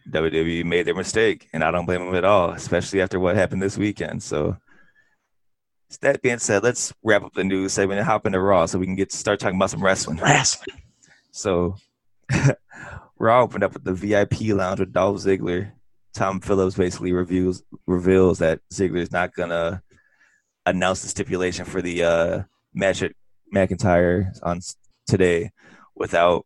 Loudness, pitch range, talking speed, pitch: -22 LUFS, 90-100 Hz, 170 wpm, 95 Hz